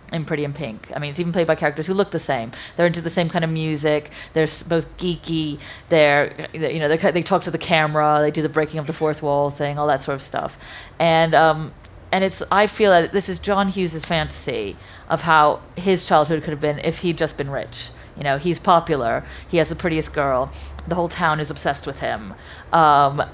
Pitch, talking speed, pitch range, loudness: 160 Hz, 225 wpm, 150-170 Hz, -20 LUFS